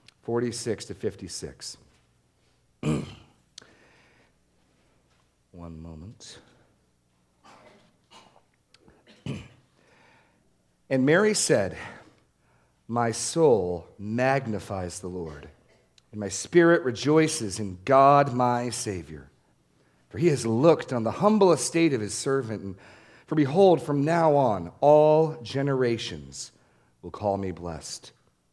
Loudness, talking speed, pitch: -24 LUFS, 95 wpm, 110 Hz